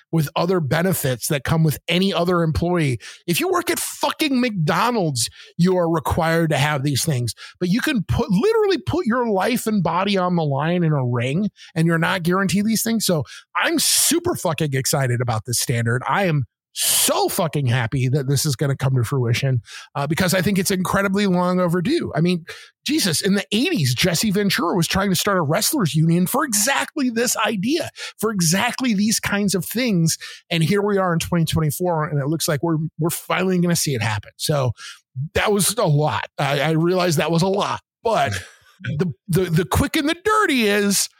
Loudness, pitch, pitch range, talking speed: -20 LUFS, 175 Hz, 150-205 Hz, 200 wpm